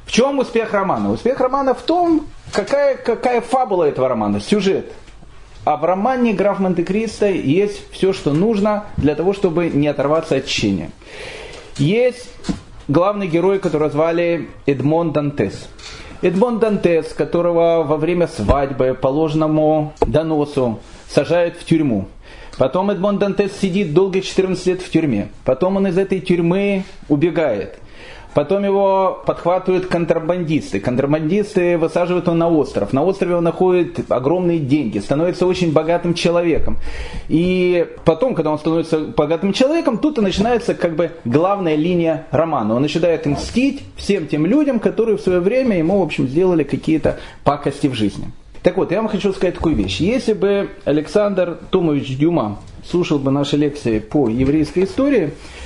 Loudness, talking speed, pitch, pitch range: -17 LUFS, 145 wpm, 175 Hz, 150-200 Hz